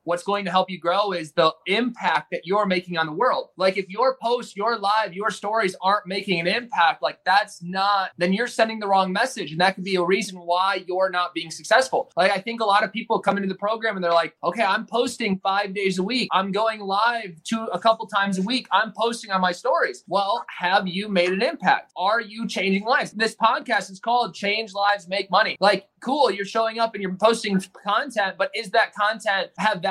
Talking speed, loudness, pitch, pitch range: 230 wpm, -22 LUFS, 200 Hz, 185-225 Hz